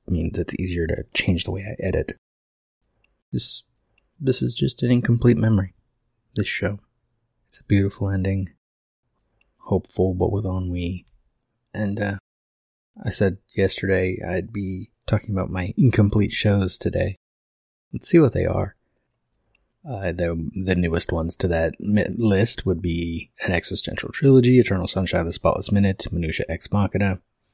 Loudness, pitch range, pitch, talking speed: -22 LUFS, 90-105 Hz, 95 Hz, 145 wpm